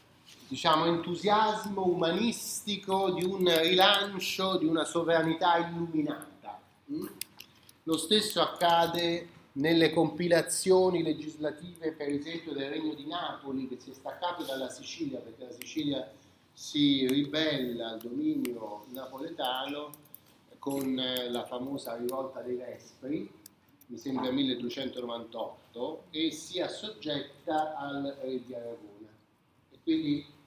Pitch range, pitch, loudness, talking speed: 130-175 Hz, 155 Hz, -31 LUFS, 105 wpm